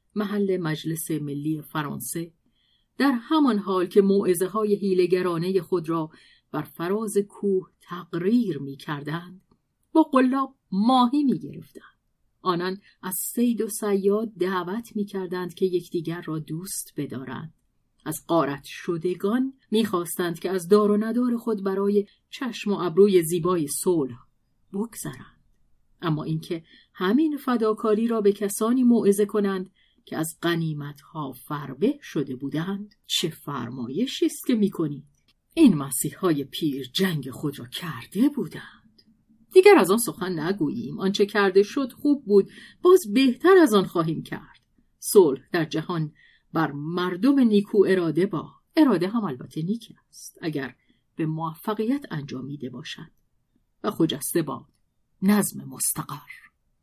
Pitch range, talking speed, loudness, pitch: 160-220 Hz, 130 wpm, -24 LUFS, 185 Hz